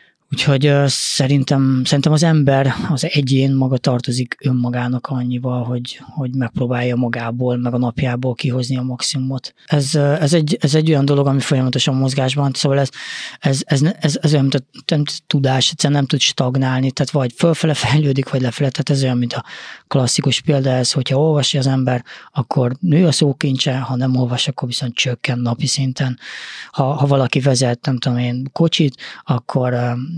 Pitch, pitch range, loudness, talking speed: 135 Hz, 125-145 Hz, -17 LUFS, 165 wpm